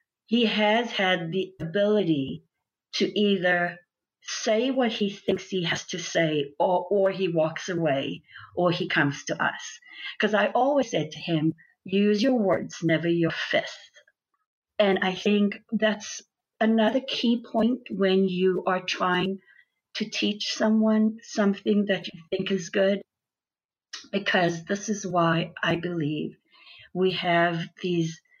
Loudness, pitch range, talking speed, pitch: -25 LUFS, 175-215 Hz, 140 wpm, 190 Hz